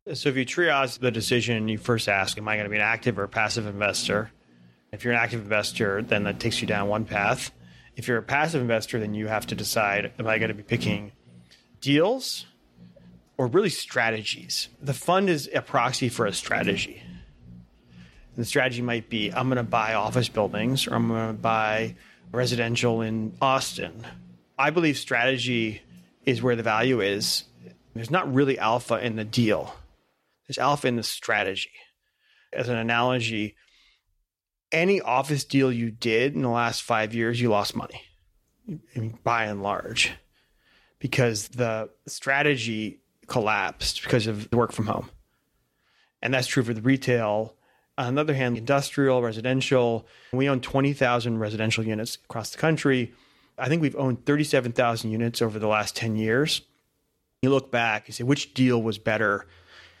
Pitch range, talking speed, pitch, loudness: 105-130 Hz, 170 wpm, 115 Hz, -25 LUFS